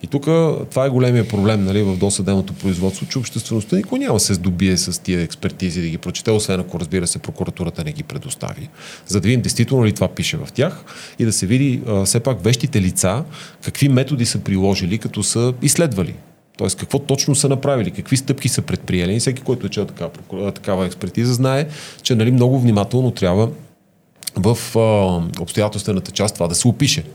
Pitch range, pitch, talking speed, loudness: 95-135 Hz, 115 Hz, 190 wpm, -18 LUFS